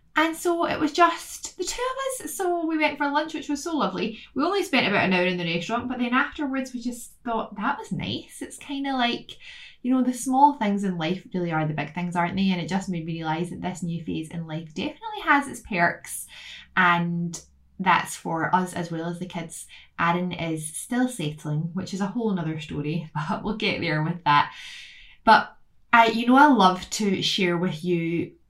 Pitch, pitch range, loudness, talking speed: 200 Hz, 170-285 Hz, -24 LUFS, 225 wpm